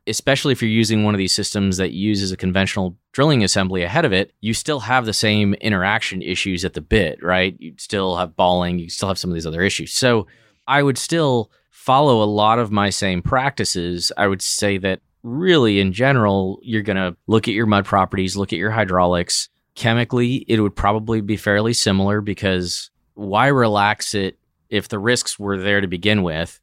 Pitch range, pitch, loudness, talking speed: 95-110 Hz, 100 Hz, -18 LUFS, 200 wpm